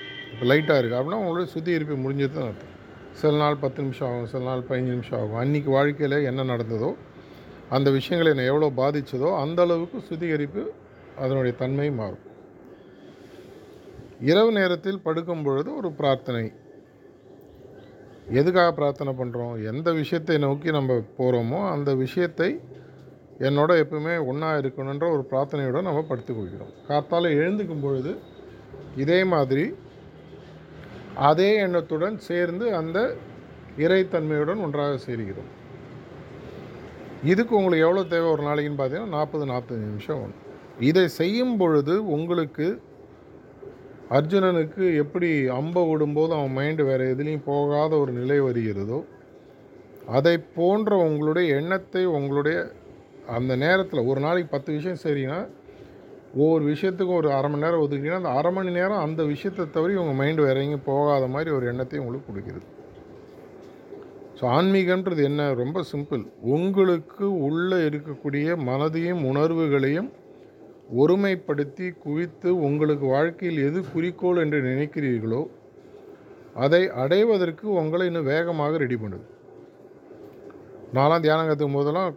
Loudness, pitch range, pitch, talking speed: -24 LUFS, 135-175 Hz, 150 Hz, 115 wpm